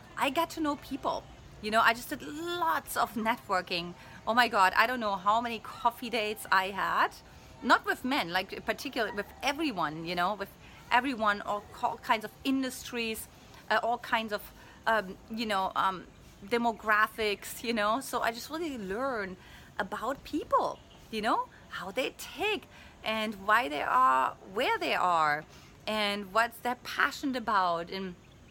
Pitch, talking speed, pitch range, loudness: 225 Hz, 160 wpm, 200-255 Hz, -30 LUFS